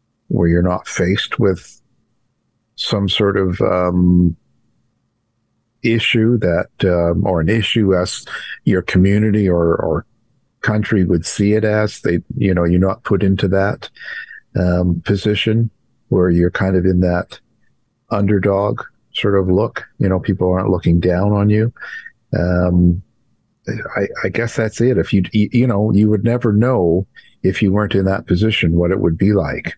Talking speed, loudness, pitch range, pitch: 155 wpm, -16 LUFS, 90-105 Hz, 95 Hz